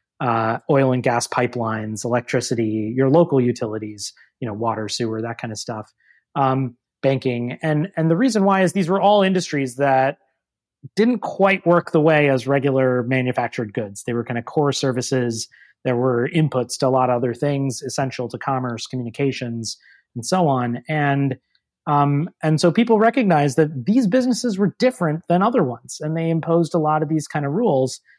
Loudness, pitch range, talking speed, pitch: -20 LUFS, 120-160 Hz, 180 wpm, 135 Hz